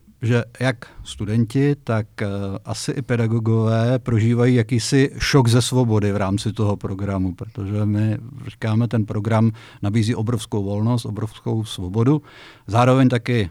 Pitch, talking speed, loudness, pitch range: 115 Hz, 125 wpm, -20 LUFS, 105-125 Hz